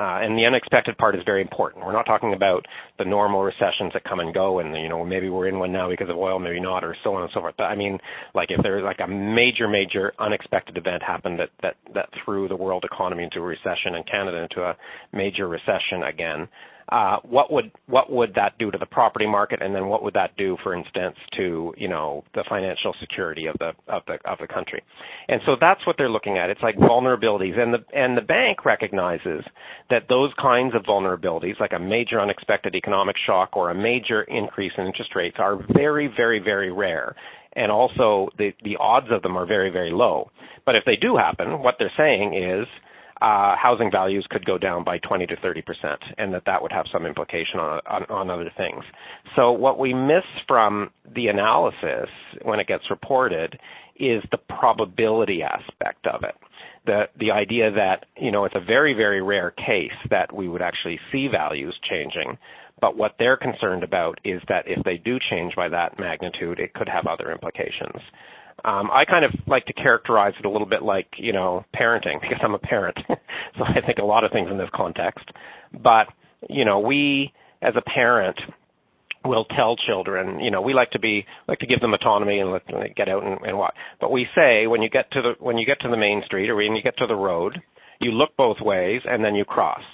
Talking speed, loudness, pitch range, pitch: 215 wpm, -22 LUFS, 95-120 Hz, 105 Hz